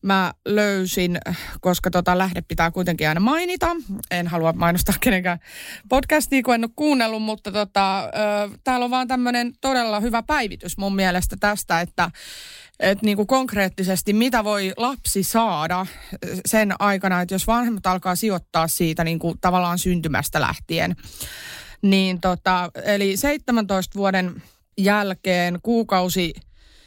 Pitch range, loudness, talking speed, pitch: 180-225 Hz, -21 LUFS, 135 wpm, 195 Hz